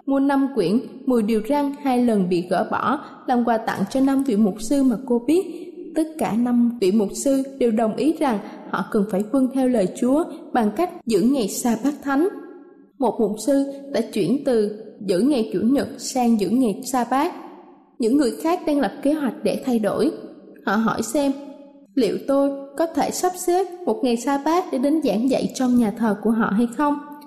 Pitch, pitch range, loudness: 260 Hz, 225-285 Hz, -21 LUFS